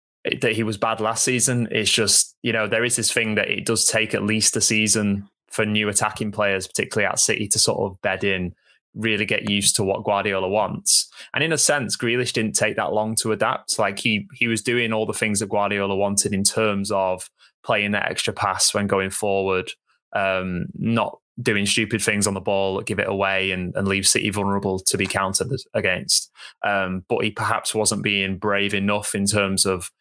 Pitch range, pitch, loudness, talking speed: 95-110 Hz, 100 Hz, -20 LUFS, 210 wpm